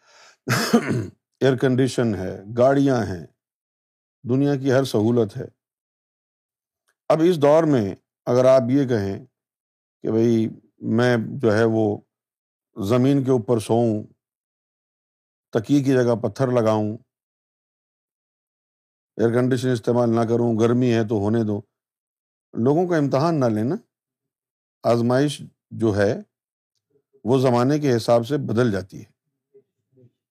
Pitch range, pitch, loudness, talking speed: 110-130 Hz, 120 Hz, -21 LUFS, 115 wpm